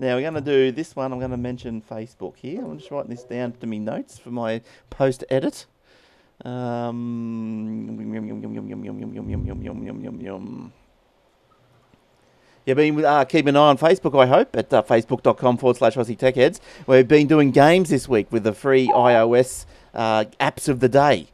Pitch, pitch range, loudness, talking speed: 125 Hz, 115-135 Hz, -20 LUFS, 160 wpm